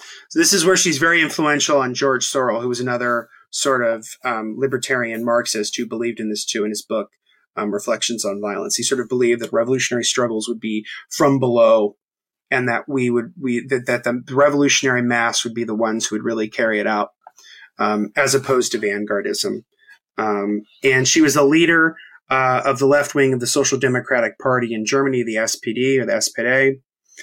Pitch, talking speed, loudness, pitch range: 125 Hz, 195 wpm, -18 LUFS, 115-135 Hz